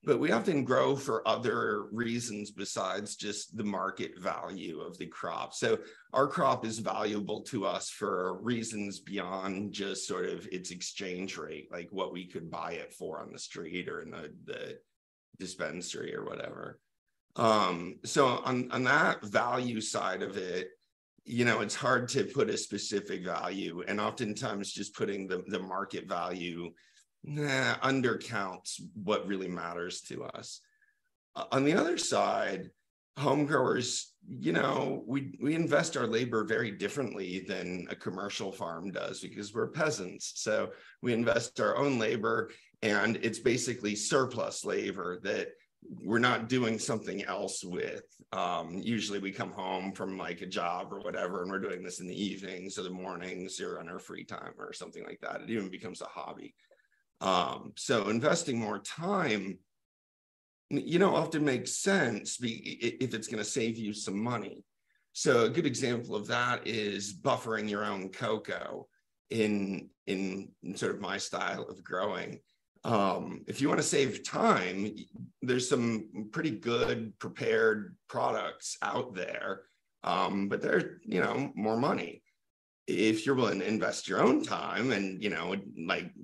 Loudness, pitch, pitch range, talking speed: -33 LUFS, 105 Hz, 95-120 Hz, 160 wpm